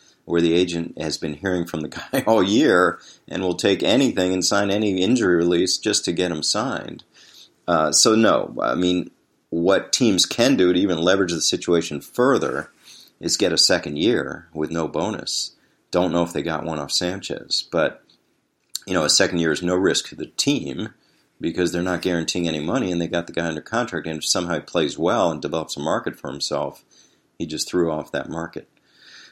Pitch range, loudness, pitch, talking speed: 80-90 Hz, -21 LUFS, 85 Hz, 205 wpm